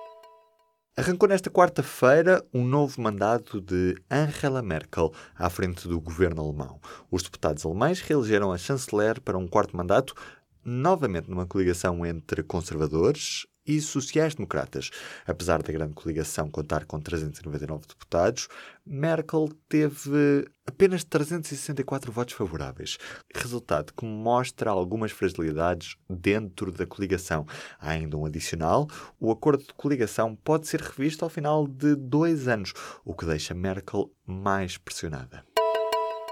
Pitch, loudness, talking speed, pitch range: 105 Hz, -27 LUFS, 125 wpm, 85-140 Hz